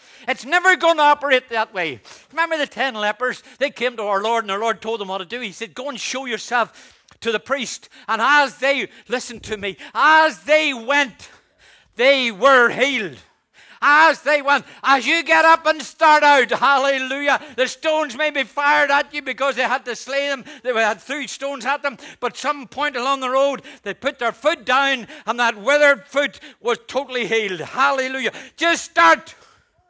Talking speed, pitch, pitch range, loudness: 195 wpm, 270 Hz, 235-290 Hz, -18 LUFS